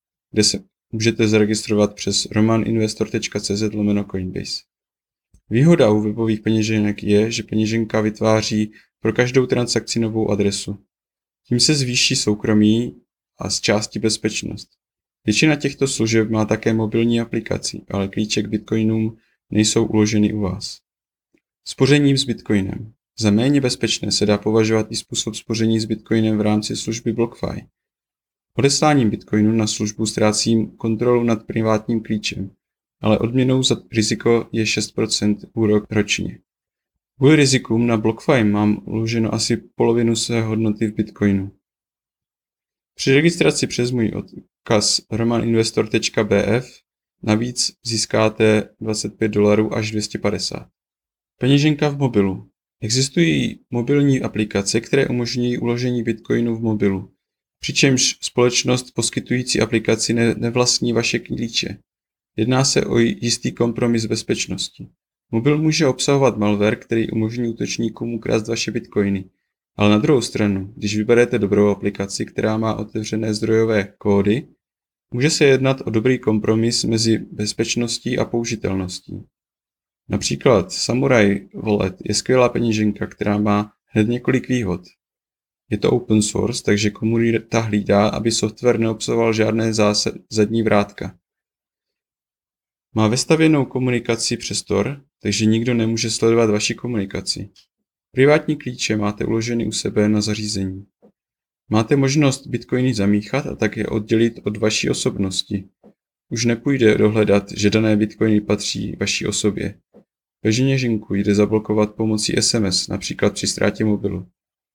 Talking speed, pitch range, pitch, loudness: 120 wpm, 105-120 Hz, 110 Hz, -19 LUFS